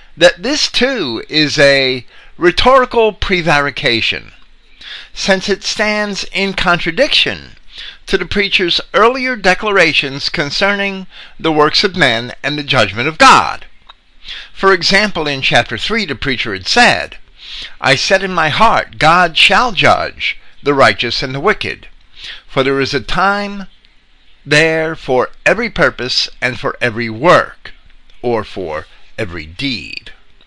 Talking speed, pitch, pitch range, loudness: 130 wpm, 160 Hz, 135-195 Hz, -12 LUFS